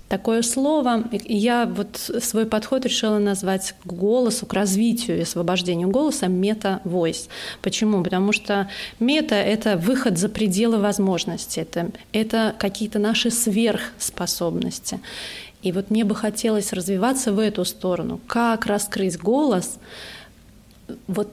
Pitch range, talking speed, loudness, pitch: 195-230 Hz, 125 wpm, -22 LUFS, 210 Hz